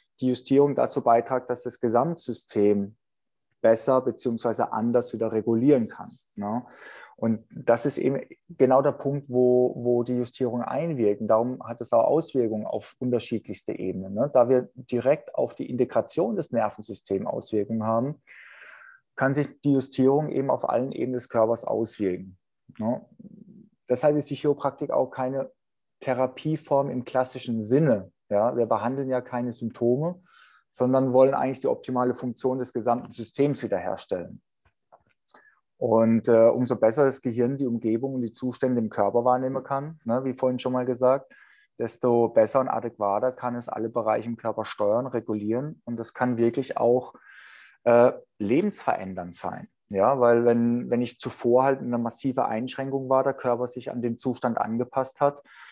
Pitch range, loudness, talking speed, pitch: 115-130 Hz, -25 LUFS, 155 wpm, 125 Hz